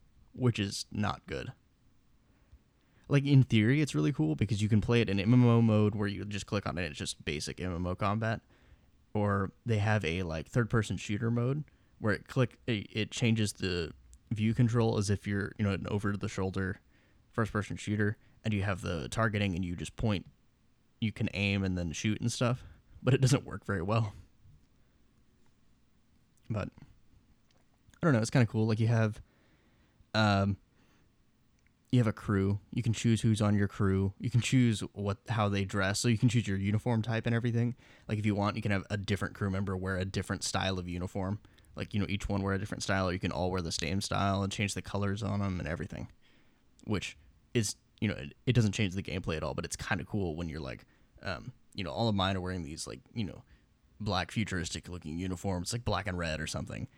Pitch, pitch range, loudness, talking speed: 100 Hz, 95-115 Hz, -32 LUFS, 210 wpm